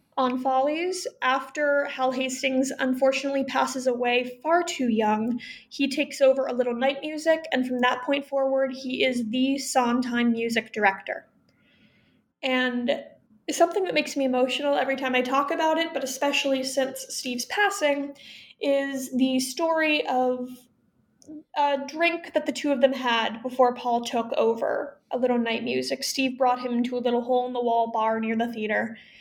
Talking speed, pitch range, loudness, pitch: 165 wpm, 245-280 Hz, -25 LUFS, 260 Hz